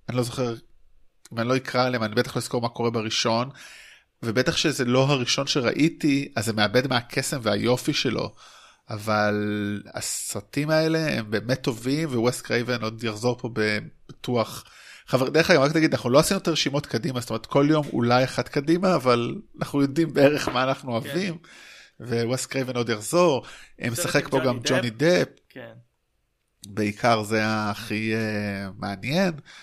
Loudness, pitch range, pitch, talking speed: -24 LUFS, 115-140 Hz, 125 Hz, 150 wpm